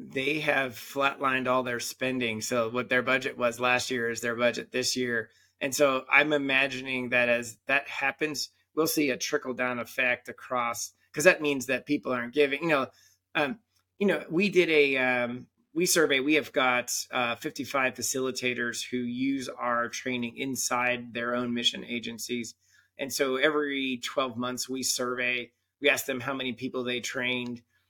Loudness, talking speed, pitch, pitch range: -28 LUFS, 175 wpm, 125 Hz, 120-135 Hz